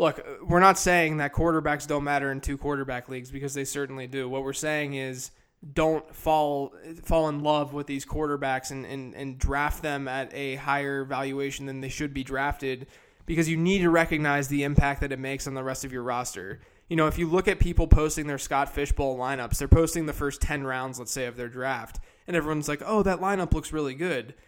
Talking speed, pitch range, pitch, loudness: 220 wpm, 135-155 Hz, 140 Hz, -27 LUFS